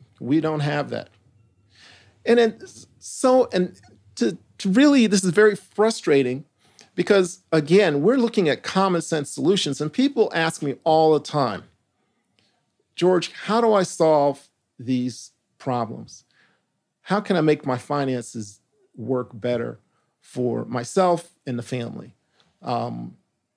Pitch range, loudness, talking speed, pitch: 125-190 Hz, -21 LUFS, 130 wpm, 150 Hz